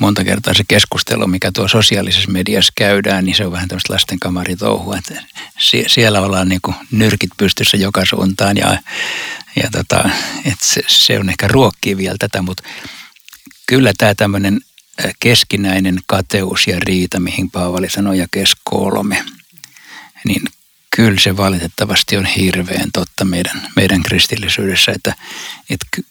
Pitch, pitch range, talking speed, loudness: 95 Hz, 95-100 Hz, 145 wpm, -13 LUFS